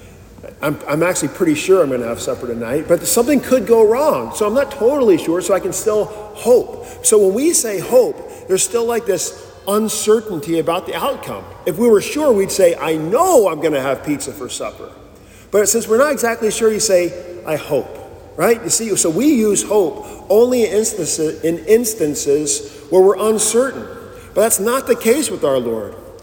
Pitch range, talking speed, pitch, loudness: 180-280 Hz, 195 wpm, 215 Hz, -16 LUFS